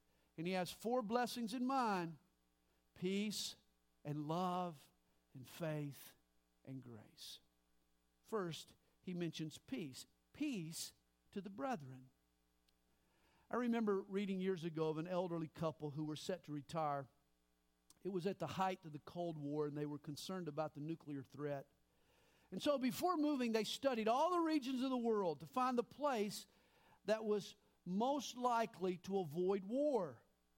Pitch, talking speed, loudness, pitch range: 170 Hz, 150 wpm, -42 LUFS, 135-215 Hz